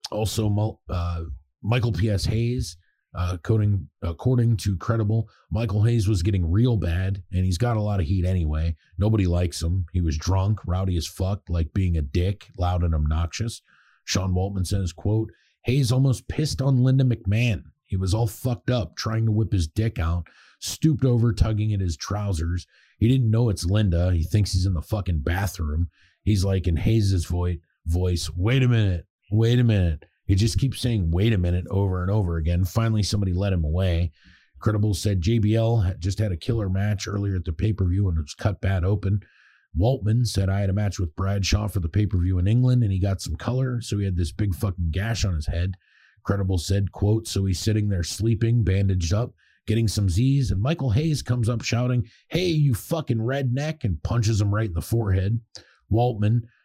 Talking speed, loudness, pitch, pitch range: 200 wpm, -24 LUFS, 100 Hz, 90-115 Hz